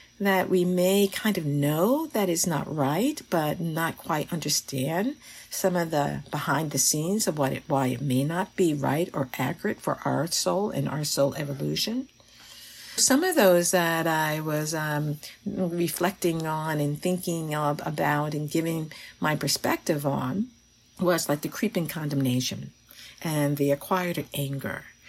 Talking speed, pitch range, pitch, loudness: 155 wpm, 145-180 Hz, 160 Hz, -26 LUFS